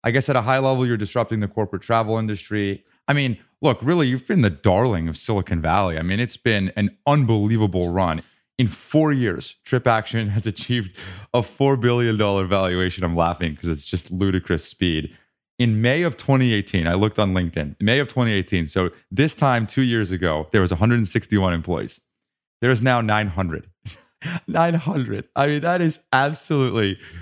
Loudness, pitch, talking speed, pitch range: -21 LUFS, 110 Hz, 175 wpm, 95-125 Hz